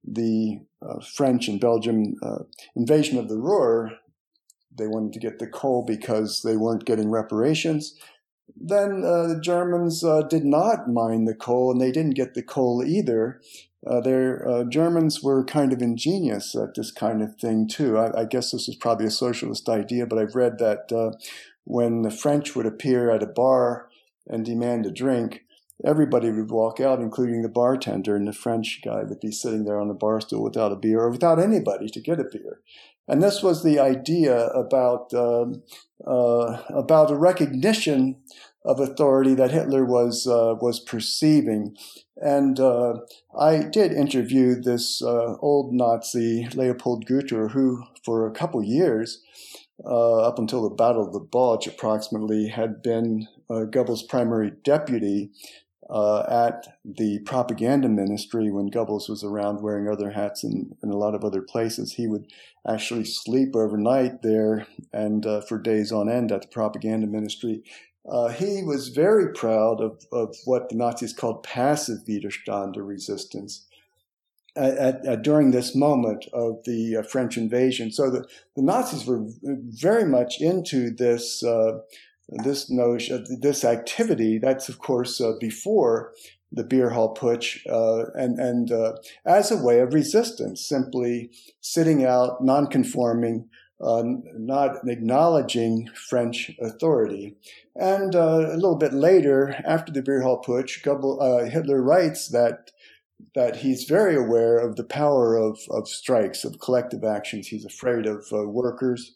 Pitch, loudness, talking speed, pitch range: 120 Hz, -23 LUFS, 165 wpm, 110-135 Hz